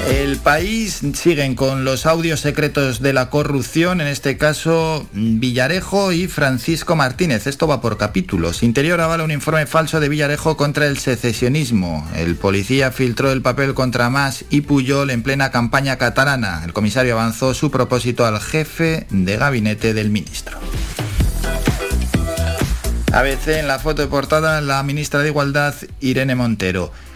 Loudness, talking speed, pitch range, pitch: -17 LUFS, 150 wpm, 120-150 Hz, 135 Hz